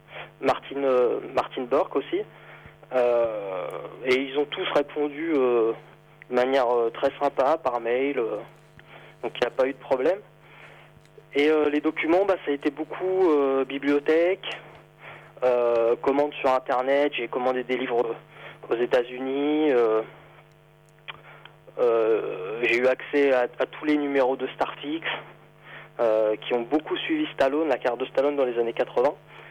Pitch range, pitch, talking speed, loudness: 125-155 Hz, 140 Hz, 155 wpm, -25 LUFS